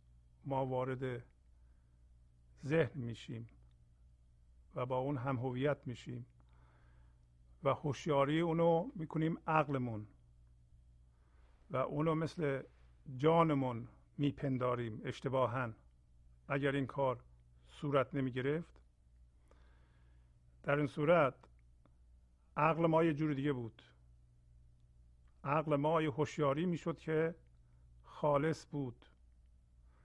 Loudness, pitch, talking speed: -37 LUFS, 115 Hz, 85 wpm